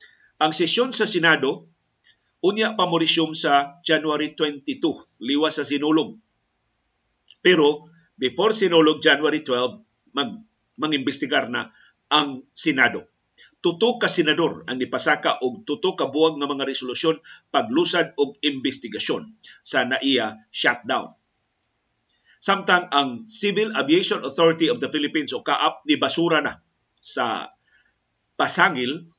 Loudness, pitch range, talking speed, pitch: -21 LUFS, 145-195 Hz, 110 wpm, 160 Hz